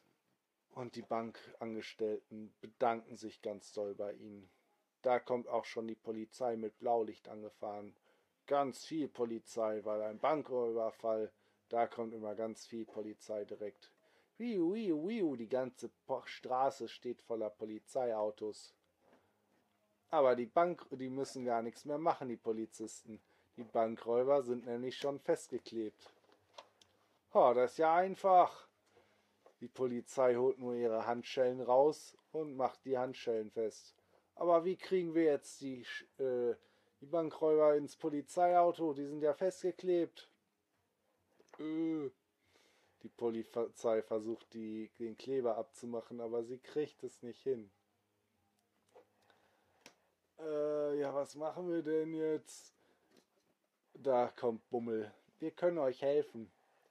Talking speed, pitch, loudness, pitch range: 125 wpm, 120 Hz, -37 LUFS, 110-145 Hz